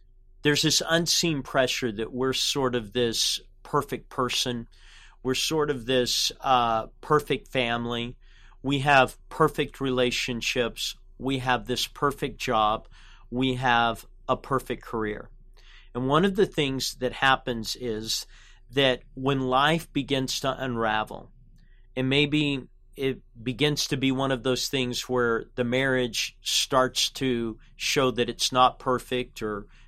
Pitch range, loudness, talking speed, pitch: 120-135 Hz, -26 LUFS, 135 wpm, 125 Hz